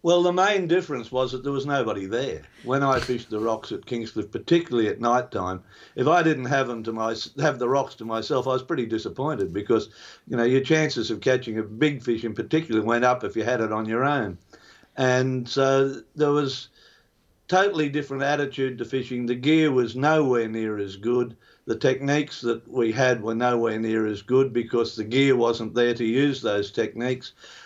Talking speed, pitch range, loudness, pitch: 200 wpm, 115-140 Hz, -24 LUFS, 125 Hz